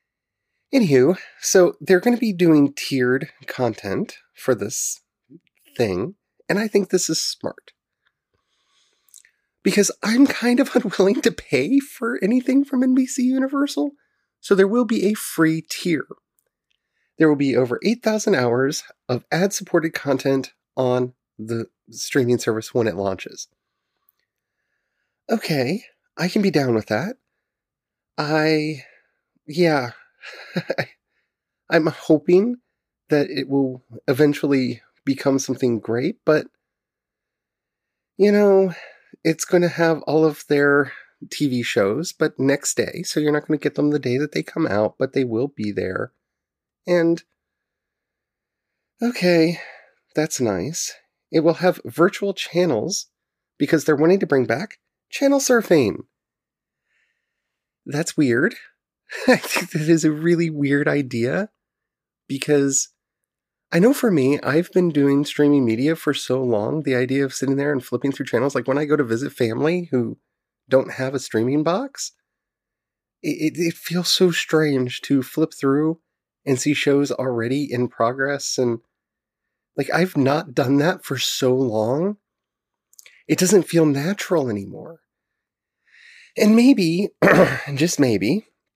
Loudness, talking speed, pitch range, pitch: -20 LUFS, 135 wpm, 135-185 Hz, 155 Hz